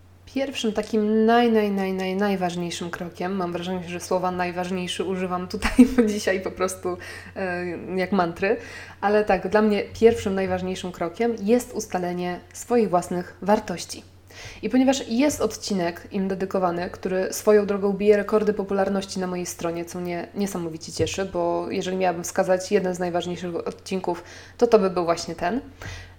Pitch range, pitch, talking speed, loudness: 180-210 Hz, 185 Hz, 155 wpm, -24 LUFS